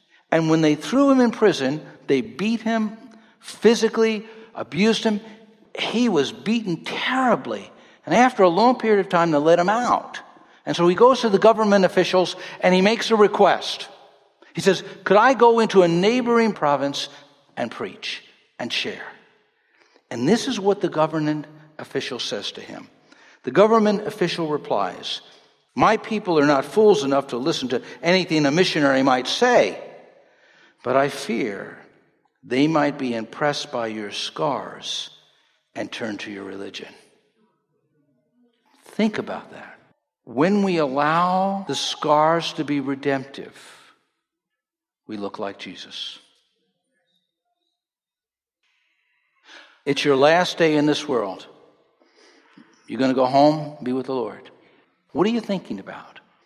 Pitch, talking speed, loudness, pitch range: 180 Hz, 140 wpm, -20 LUFS, 145-220 Hz